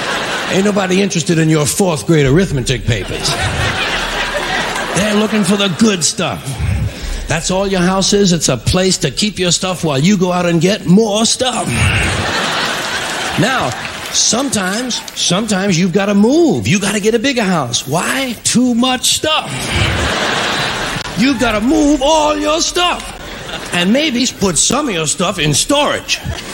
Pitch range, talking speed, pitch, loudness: 170-235 Hz, 155 wpm, 200 Hz, -13 LUFS